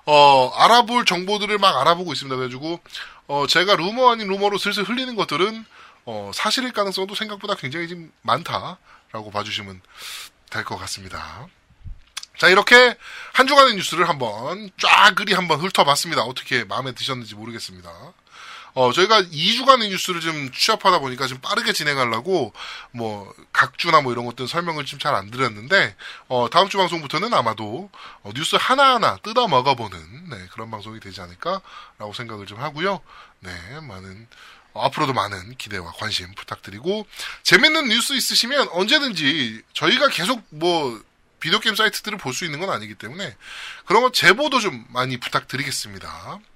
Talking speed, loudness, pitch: 355 characters per minute, -19 LUFS, 160 Hz